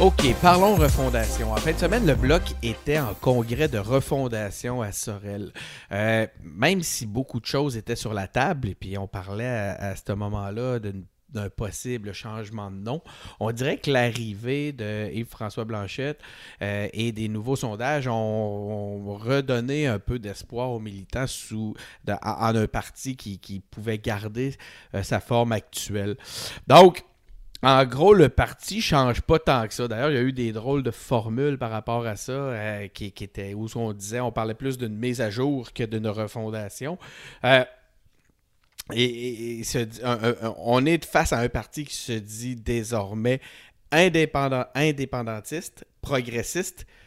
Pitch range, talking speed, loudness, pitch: 105-130 Hz, 175 wpm, -25 LUFS, 115 Hz